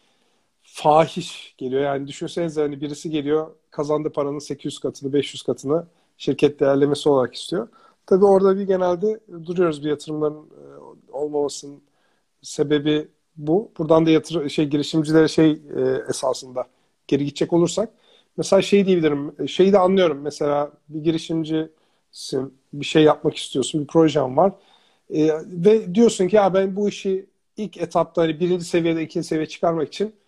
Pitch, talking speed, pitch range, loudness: 160 Hz, 140 wpm, 150-180 Hz, -21 LUFS